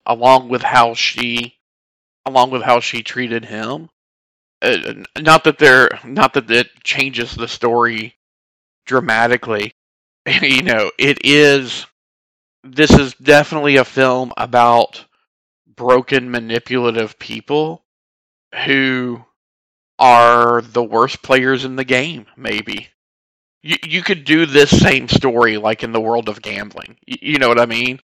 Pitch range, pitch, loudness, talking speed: 110-130 Hz, 120 Hz, -14 LUFS, 135 wpm